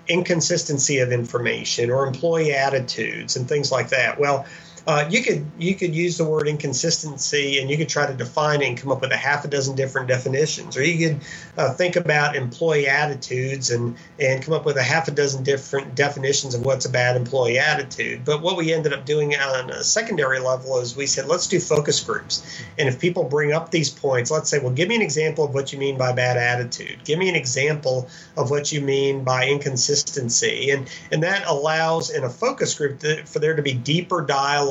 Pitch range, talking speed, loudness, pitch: 135-160 Hz, 215 wpm, -21 LUFS, 145 Hz